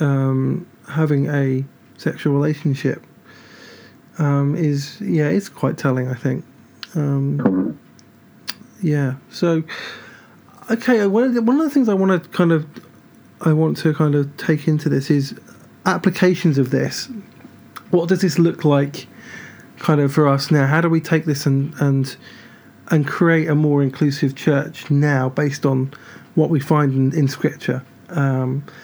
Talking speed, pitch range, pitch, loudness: 155 wpm, 140-170 Hz, 150 Hz, -19 LUFS